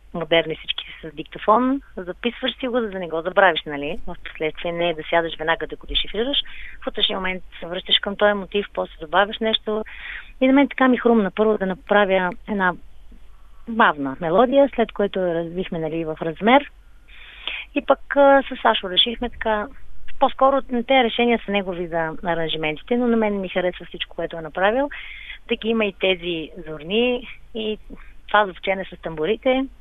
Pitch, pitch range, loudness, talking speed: 200 Hz, 170-235 Hz, -21 LUFS, 175 wpm